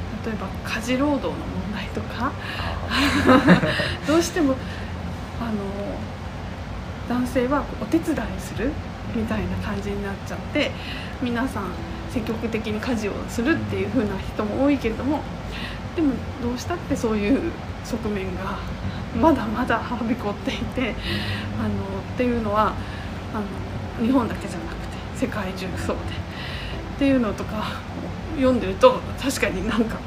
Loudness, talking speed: -24 LUFS, 270 characters per minute